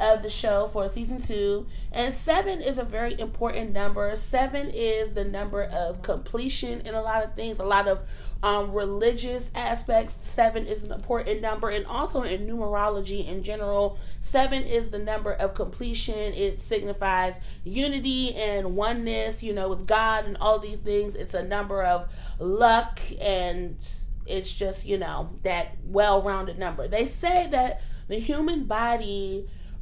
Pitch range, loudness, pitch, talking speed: 200-230 Hz, -27 LUFS, 210 Hz, 160 wpm